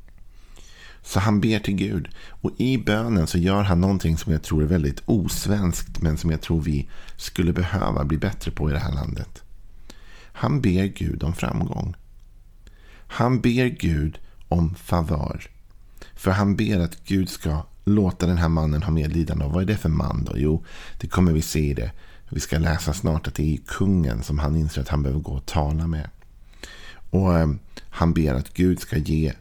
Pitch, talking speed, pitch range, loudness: 85 Hz, 190 wpm, 75-95 Hz, -23 LUFS